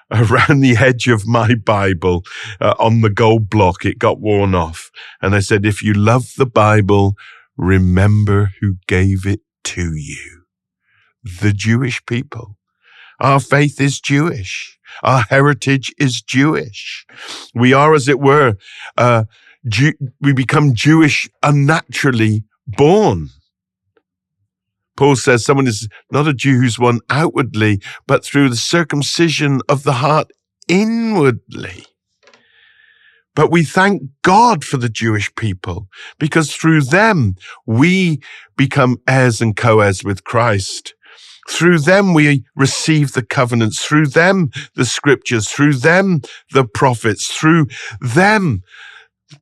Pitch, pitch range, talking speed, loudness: 125 Hz, 105-145 Hz, 125 wpm, -14 LUFS